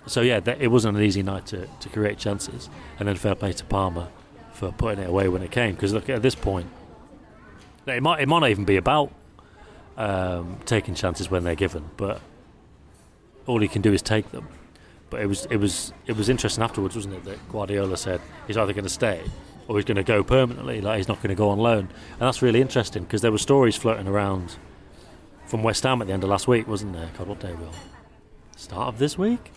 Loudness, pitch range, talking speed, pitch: -24 LUFS, 95-115 Hz, 230 wpm, 100 Hz